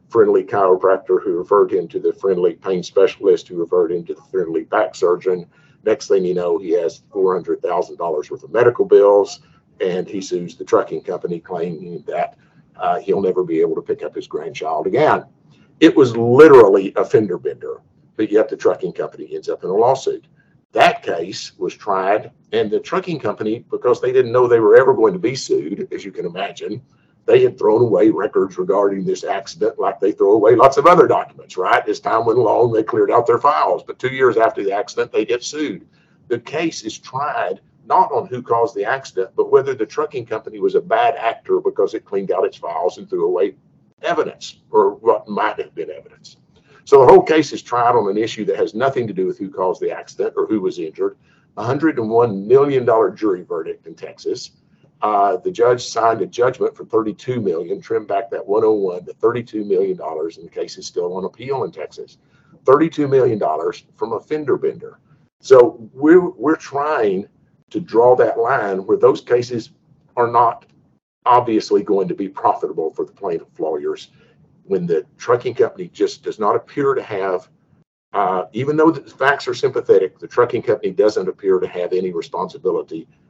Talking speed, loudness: 195 wpm, -17 LUFS